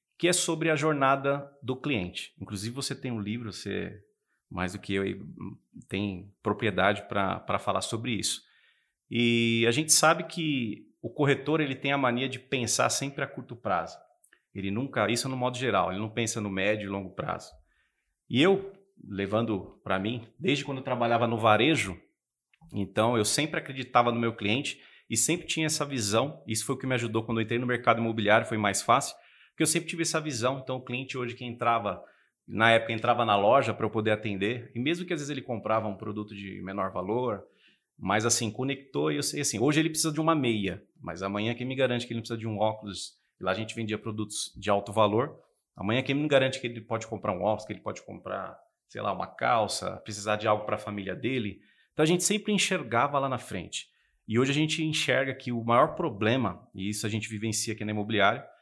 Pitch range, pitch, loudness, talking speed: 105-135 Hz, 115 Hz, -28 LUFS, 215 wpm